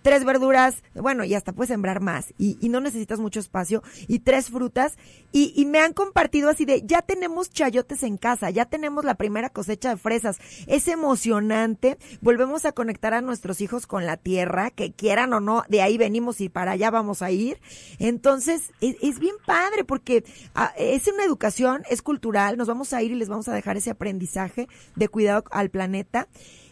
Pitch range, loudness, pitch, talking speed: 210-275 Hz, -23 LUFS, 235 Hz, 195 wpm